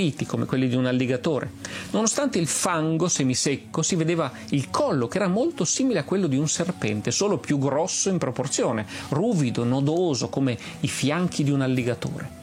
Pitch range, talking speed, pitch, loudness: 130-175 Hz, 170 wpm, 145 Hz, -24 LUFS